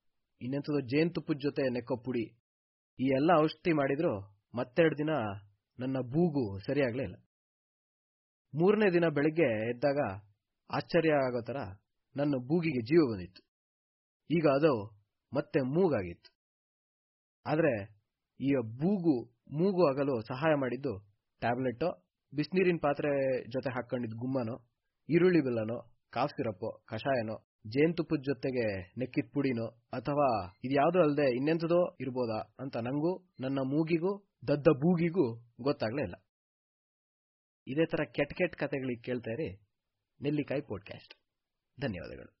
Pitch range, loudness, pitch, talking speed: 115-155 Hz, -32 LUFS, 135 Hz, 105 wpm